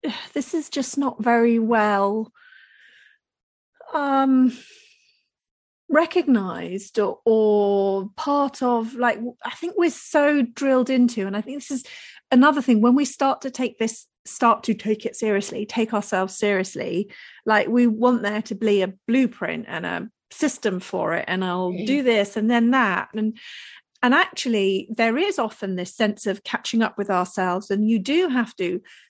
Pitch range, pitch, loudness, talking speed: 205-260 Hz, 230 Hz, -22 LUFS, 160 wpm